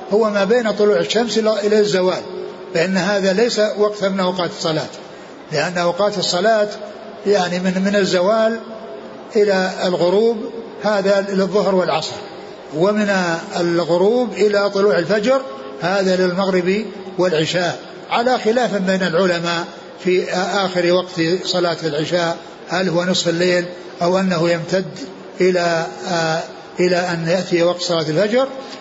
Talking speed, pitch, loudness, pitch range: 120 wpm, 185 Hz, -17 LUFS, 175-210 Hz